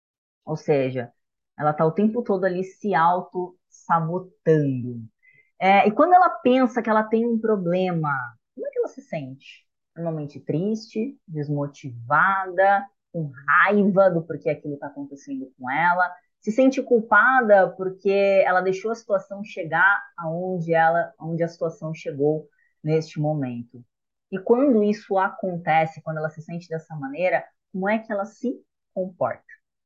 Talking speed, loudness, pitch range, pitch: 140 wpm, -22 LUFS, 155-210 Hz, 180 Hz